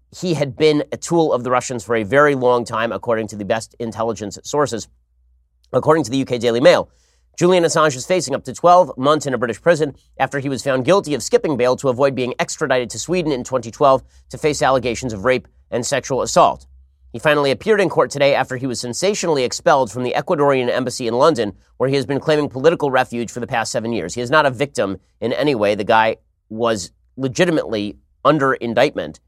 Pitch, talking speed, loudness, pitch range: 130 Hz, 215 wpm, -18 LUFS, 115-150 Hz